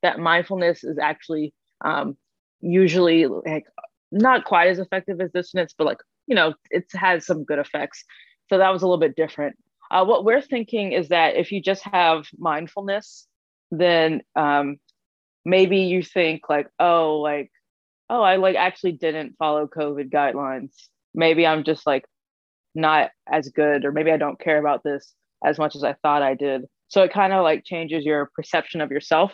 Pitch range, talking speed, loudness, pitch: 150-185 Hz, 180 wpm, -21 LUFS, 165 Hz